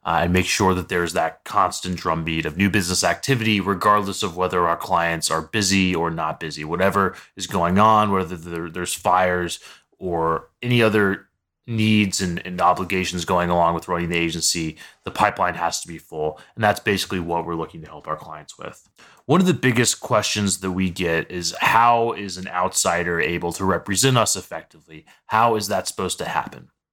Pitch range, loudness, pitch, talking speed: 85-100 Hz, -21 LUFS, 90 Hz, 185 wpm